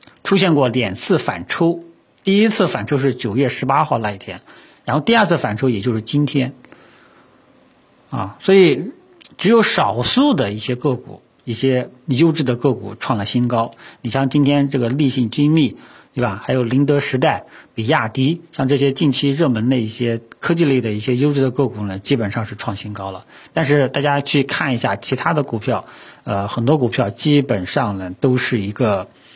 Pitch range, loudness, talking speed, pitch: 115-150 Hz, -17 LUFS, 270 characters per minute, 135 Hz